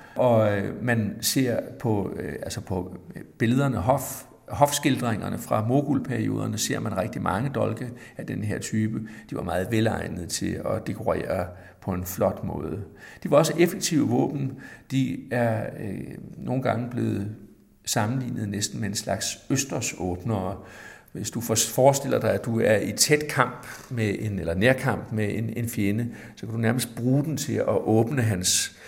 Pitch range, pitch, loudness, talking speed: 105-130 Hz, 115 Hz, -25 LUFS, 160 wpm